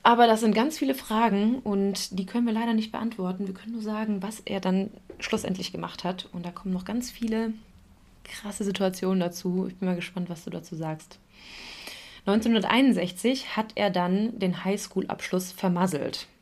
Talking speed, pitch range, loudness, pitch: 170 wpm, 185-225 Hz, -27 LUFS, 200 Hz